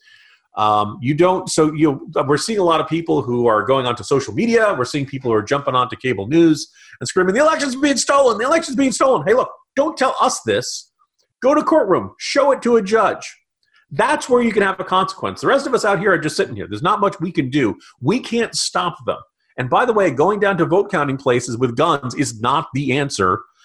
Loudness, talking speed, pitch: -17 LUFS, 235 wpm, 185 Hz